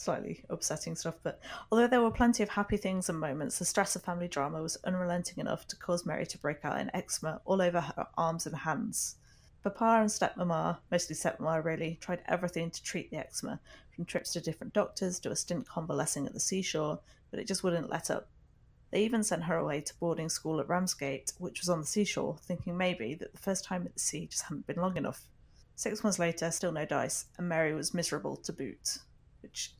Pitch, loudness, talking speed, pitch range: 175 Hz, -34 LUFS, 215 wpm, 160-190 Hz